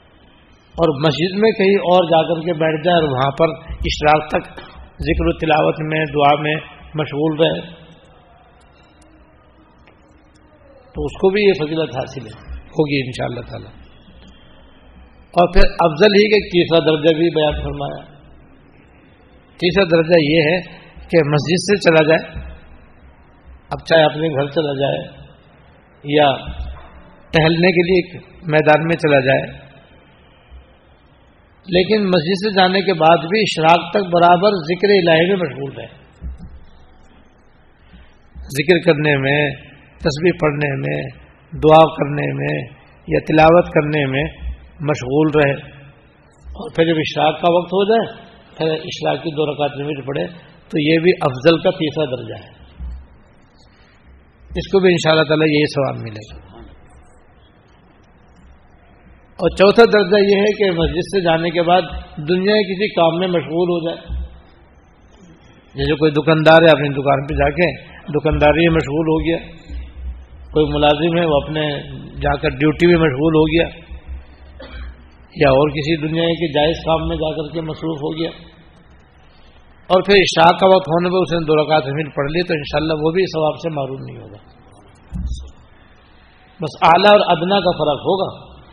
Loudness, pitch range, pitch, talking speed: -16 LUFS, 130-170 Hz, 155 Hz, 150 wpm